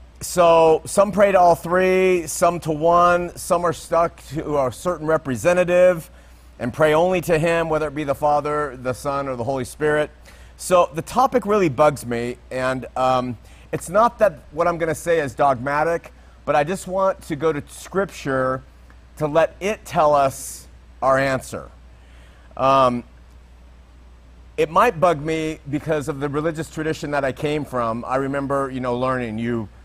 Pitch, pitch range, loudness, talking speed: 150 Hz, 125-170 Hz, -20 LUFS, 170 wpm